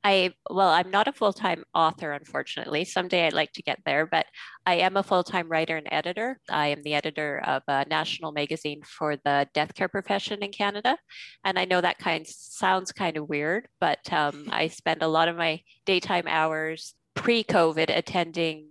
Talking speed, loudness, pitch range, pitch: 190 wpm, -26 LUFS, 155-190 Hz, 165 Hz